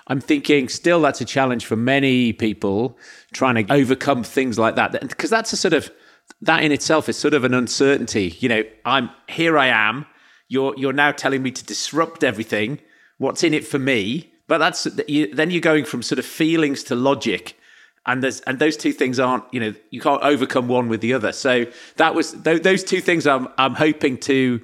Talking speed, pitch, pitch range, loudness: 205 wpm, 135 Hz, 125-155 Hz, -19 LUFS